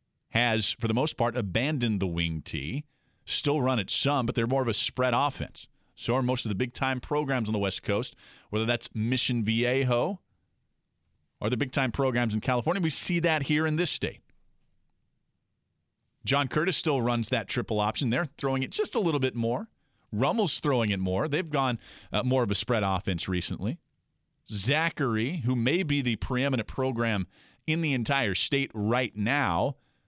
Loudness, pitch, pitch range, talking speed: -28 LUFS, 125 Hz, 110-140 Hz, 180 wpm